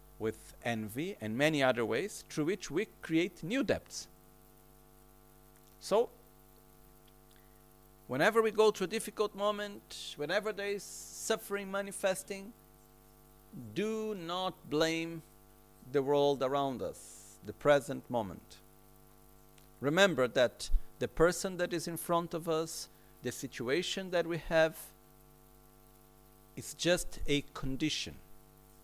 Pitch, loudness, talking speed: 145 Hz, -34 LUFS, 110 wpm